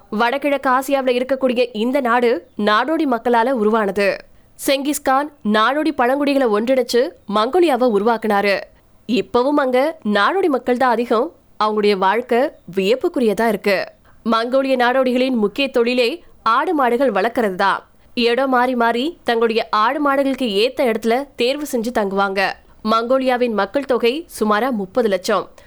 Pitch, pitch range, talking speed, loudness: 245 Hz, 220-270 Hz, 95 wpm, -18 LUFS